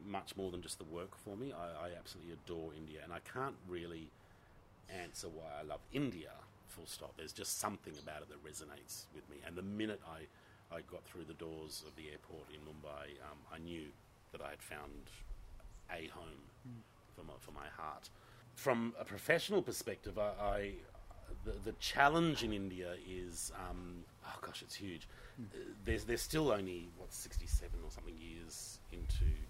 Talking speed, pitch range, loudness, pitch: 185 wpm, 80-110 Hz, -43 LUFS, 90 Hz